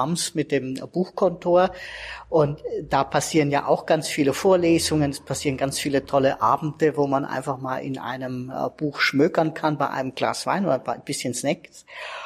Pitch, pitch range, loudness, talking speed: 145 Hz, 135-165 Hz, -23 LUFS, 170 wpm